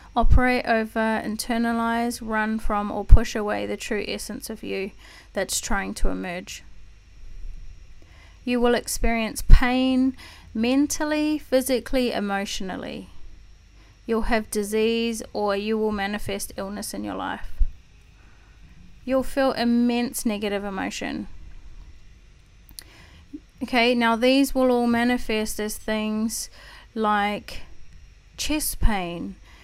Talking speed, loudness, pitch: 105 wpm, -24 LUFS, 215 Hz